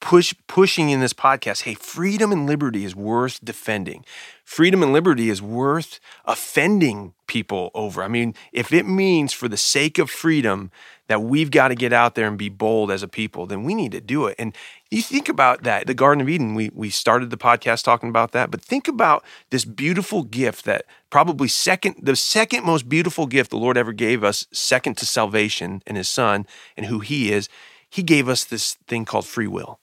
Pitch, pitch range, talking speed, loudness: 125 Hz, 110-160 Hz, 205 wpm, -20 LUFS